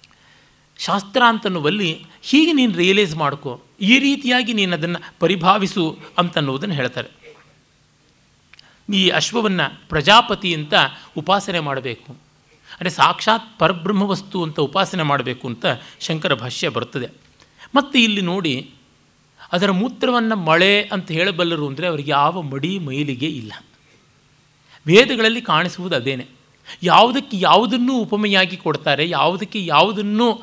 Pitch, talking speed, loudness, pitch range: 180 Hz, 105 wpm, -17 LUFS, 155-210 Hz